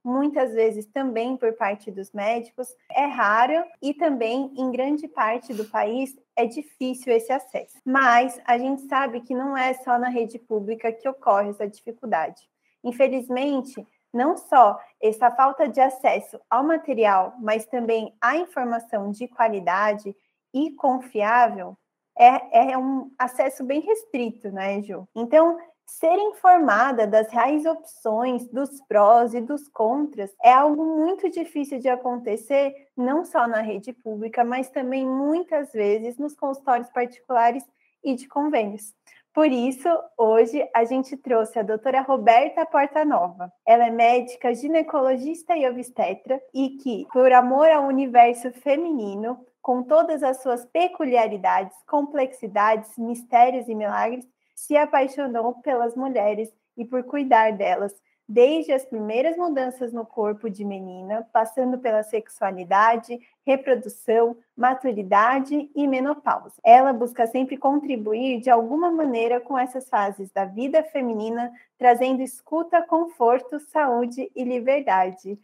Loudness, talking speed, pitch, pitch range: -22 LUFS, 135 wpm, 255 Hz, 230-280 Hz